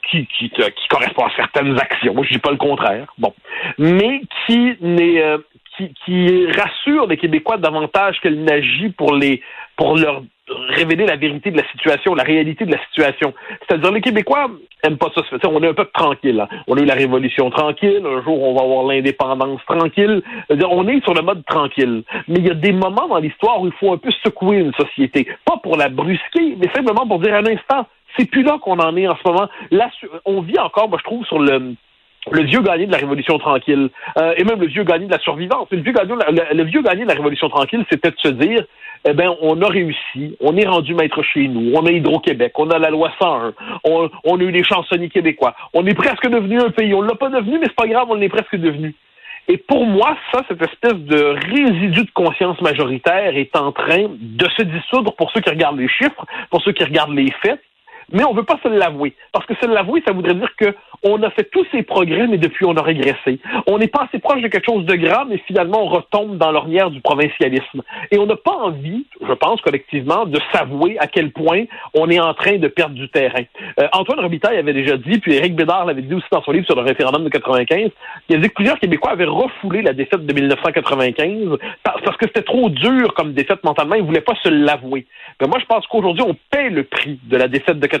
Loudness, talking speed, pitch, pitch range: -16 LUFS, 235 wpm, 175 Hz, 150-220 Hz